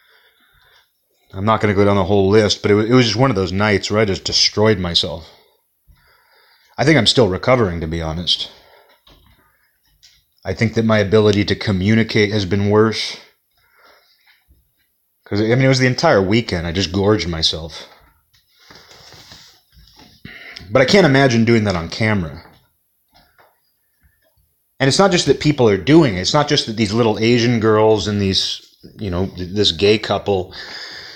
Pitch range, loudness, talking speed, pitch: 95-120 Hz, -15 LUFS, 160 wpm, 105 Hz